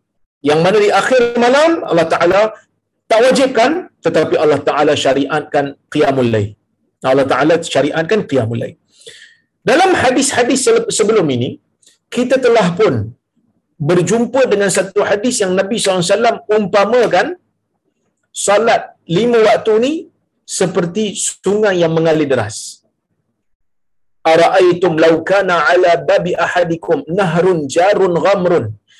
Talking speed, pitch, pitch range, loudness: 110 wpm, 190 Hz, 160-235 Hz, -13 LUFS